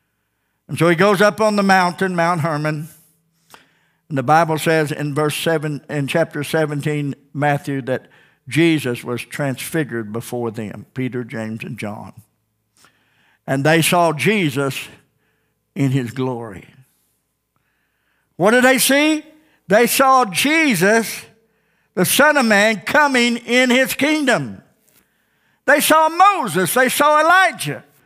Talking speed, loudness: 125 wpm, -16 LUFS